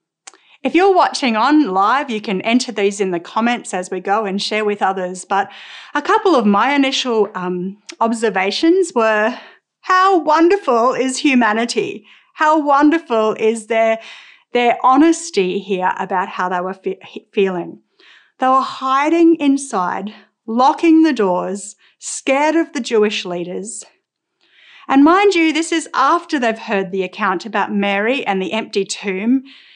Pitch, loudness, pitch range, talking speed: 230 Hz, -16 LUFS, 200-295 Hz, 145 wpm